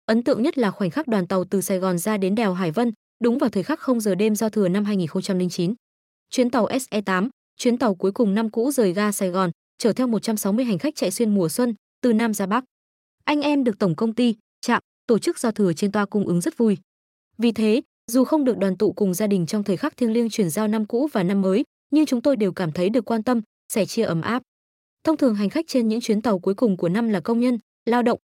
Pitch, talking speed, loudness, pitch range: 220 Hz, 260 wpm, -22 LUFS, 195-245 Hz